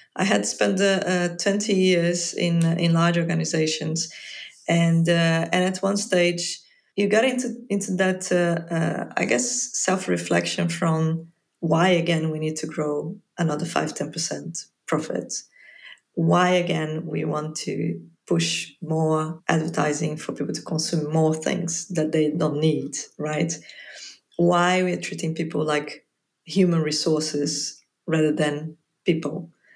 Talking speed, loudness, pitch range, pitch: 140 wpm, -23 LUFS, 155-175 Hz, 165 Hz